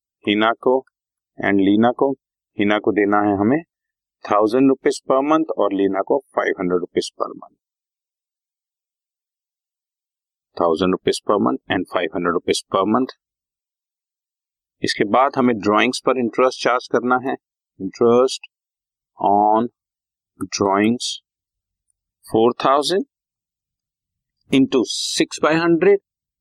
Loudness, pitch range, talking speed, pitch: -19 LUFS, 100-130 Hz, 110 wpm, 110 Hz